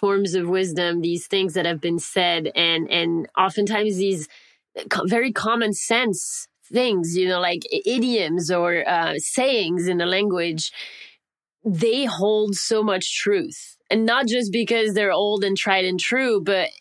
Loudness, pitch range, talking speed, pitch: -21 LUFS, 175-230 Hz, 155 wpm, 195 Hz